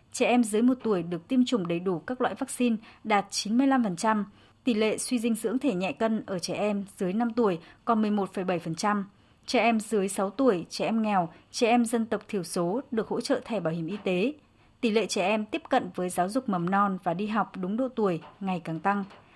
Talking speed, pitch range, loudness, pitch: 225 wpm, 185-235 Hz, -28 LUFS, 210 Hz